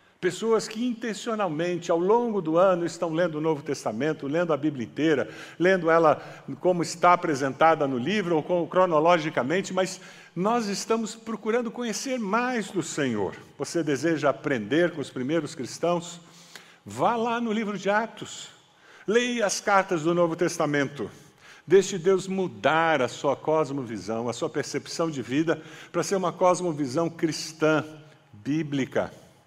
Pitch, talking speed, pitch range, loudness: 170 Hz, 145 wpm, 155-195 Hz, -25 LUFS